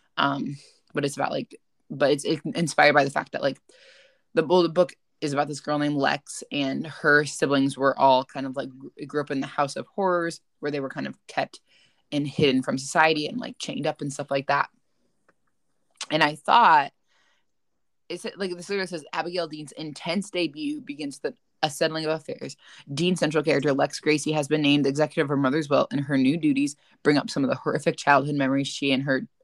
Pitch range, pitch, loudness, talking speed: 140-170 Hz, 150 Hz, -25 LUFS, 210 wpm